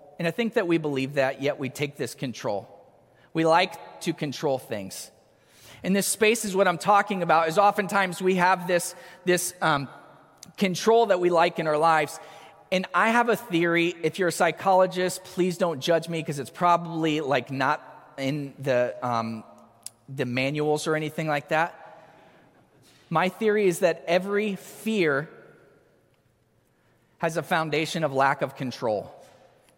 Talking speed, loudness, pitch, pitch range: 160 wpm, -25 LUFS, 165 Hz, 145-185 Hz